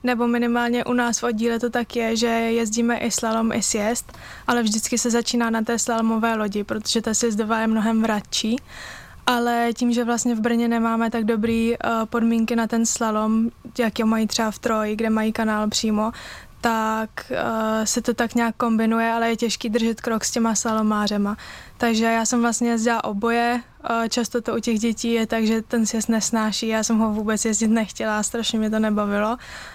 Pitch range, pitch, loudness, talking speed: 220-235 Hz, 230 Hz, -22 LUFS, 195 wpm